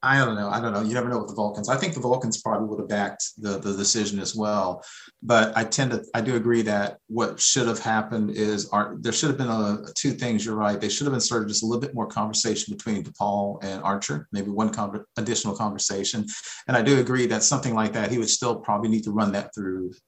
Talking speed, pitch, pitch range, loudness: 255 wpm, 110 Hz, 100-115 Hz, -24 LUFS